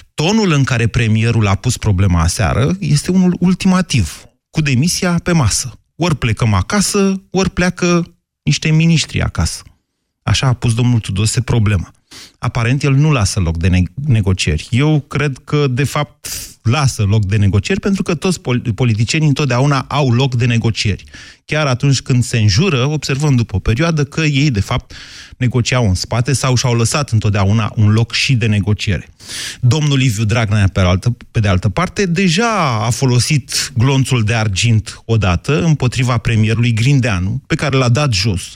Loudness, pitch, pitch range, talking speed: -15 LUFS, 125 Hz, 110-150 Hz, 165 wpm